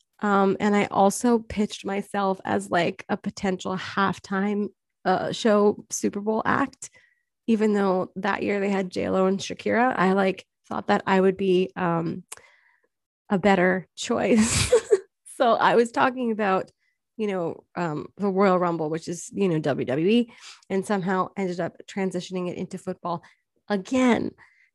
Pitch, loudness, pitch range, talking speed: 195 Hz, -24 LUFS, 185-210 Hz, 150 wpm